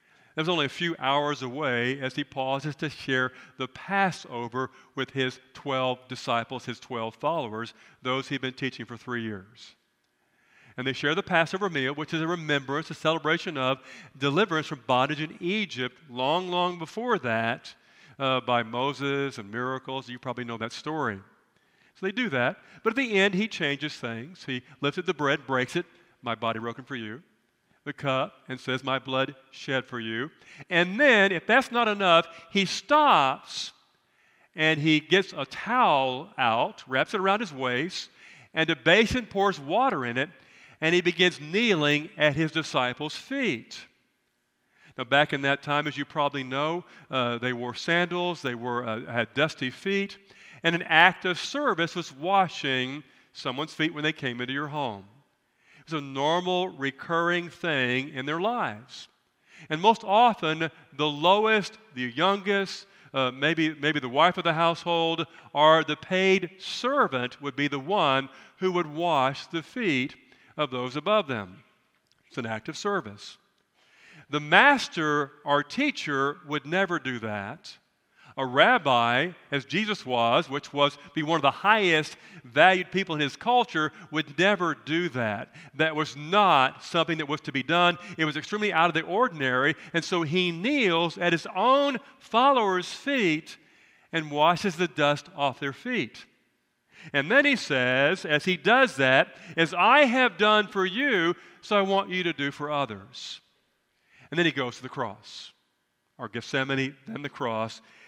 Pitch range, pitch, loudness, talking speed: 130-180 Hz, 150 Hz, -26 LUFS, 165 wpm